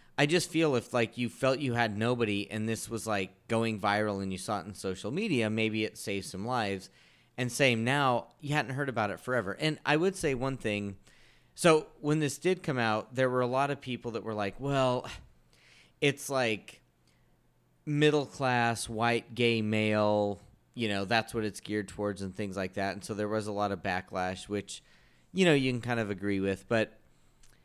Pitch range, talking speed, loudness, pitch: 100-130 Hz, 205 wpm, -31 LUFS, 110 Hz